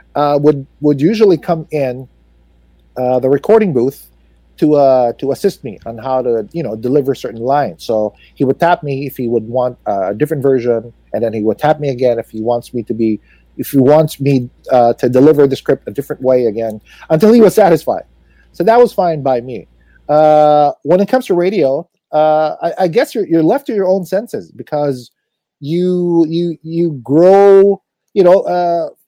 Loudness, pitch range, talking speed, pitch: -13 LUFS, 120-170 Hz, 200 wpm, 140 Hz